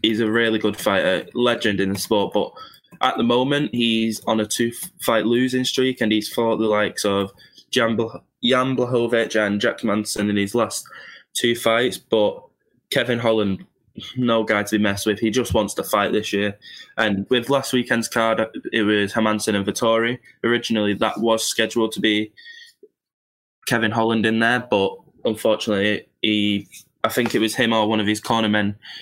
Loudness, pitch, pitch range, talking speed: -20 LUFS, 110 Hz, 105-120 Hz, 175 wpm